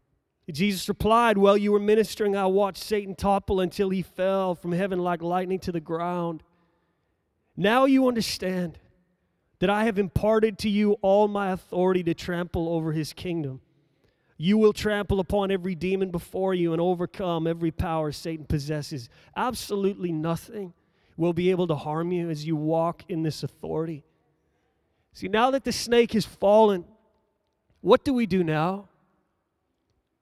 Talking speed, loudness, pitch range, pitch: 155 wpm, -25 LUFS, 165-205 Hz, 185 Hz